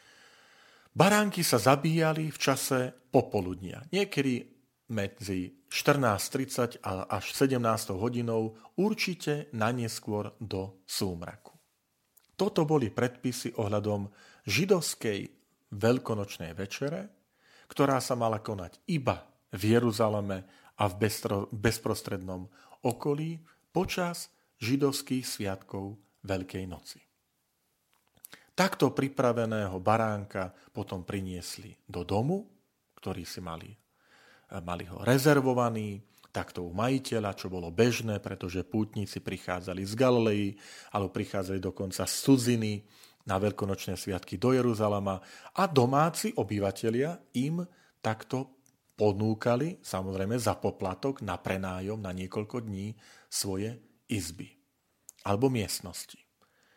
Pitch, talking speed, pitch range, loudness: 110 Hz, 95 wpm, 100-130 Hz, -31 LUFS